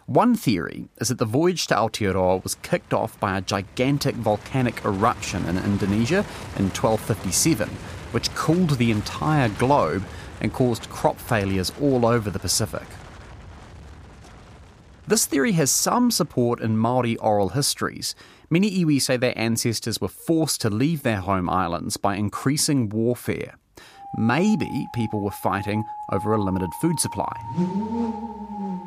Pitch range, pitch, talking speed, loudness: 100-145 Hz, 115 Hz, 135 wpm, -23 LUFS